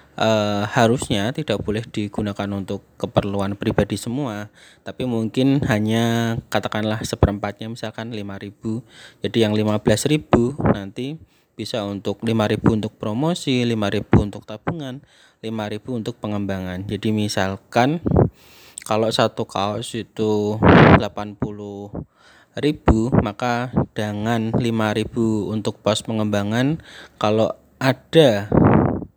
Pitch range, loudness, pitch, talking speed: 105-120 Hz, -21 LUFS, 110 Hz, 95 wpm